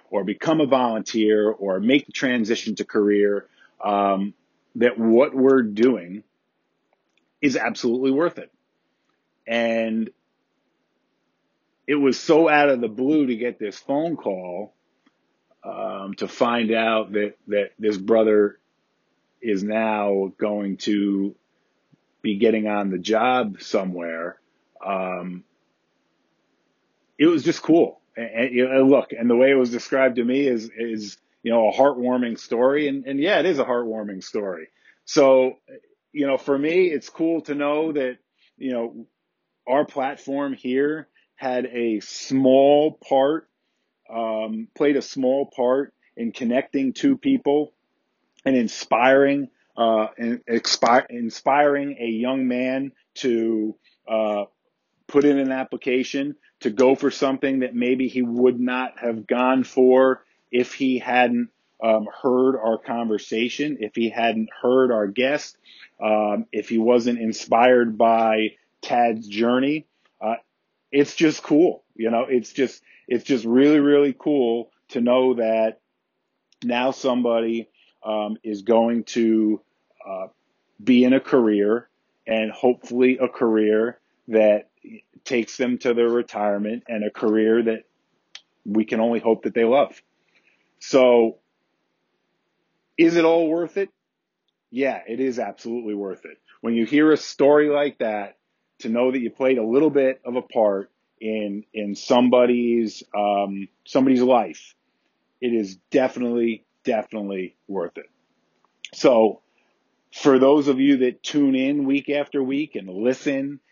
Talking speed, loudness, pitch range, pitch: 140 wpm, -21 LUFS, 110-135 Hz, 120 Hz